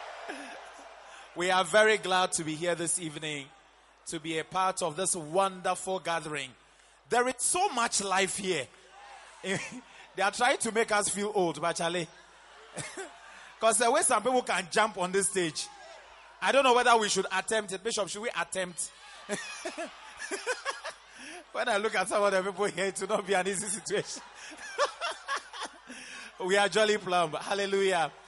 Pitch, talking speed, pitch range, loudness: 195 Hz, 160 wpm, 180-220 Hz, -29 LUFS